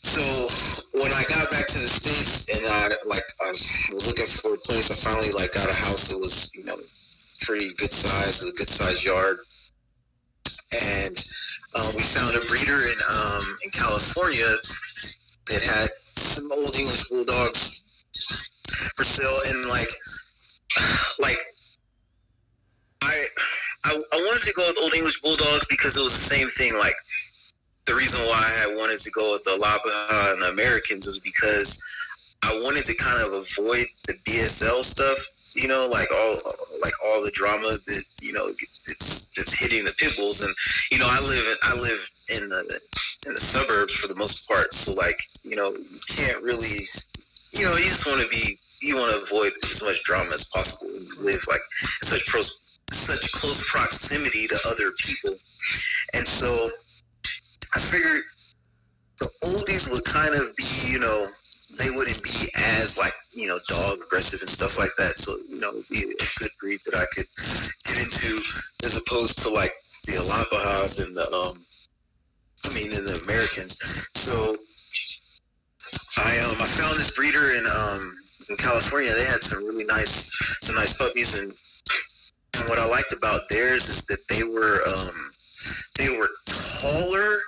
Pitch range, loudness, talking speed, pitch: 100-145 Hz, -20 LUFS, 170 wpm, 115 Hz